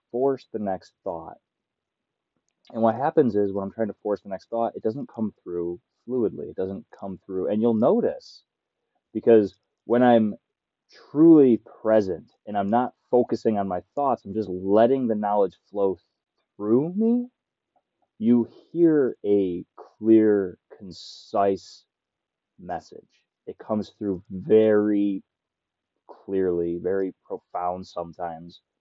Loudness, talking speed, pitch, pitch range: -23 LUFS, 130 wpm, 105 Hz, 95-115 Hz